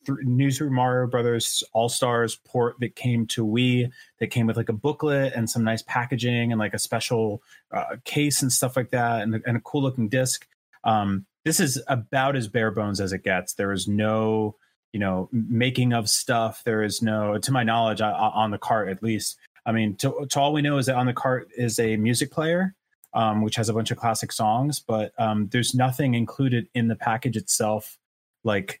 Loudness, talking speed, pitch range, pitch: -24 LUFS, 210 wpm, 110-130 Hz, 115 Hz